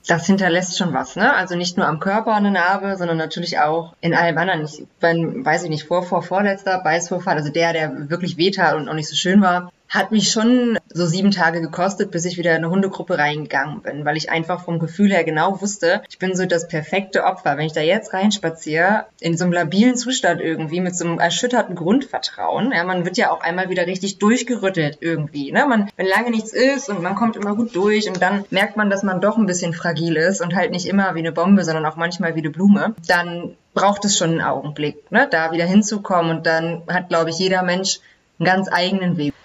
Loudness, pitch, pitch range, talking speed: -19 LUFS, 180 Hz, 165-195 Hz, 230 wpm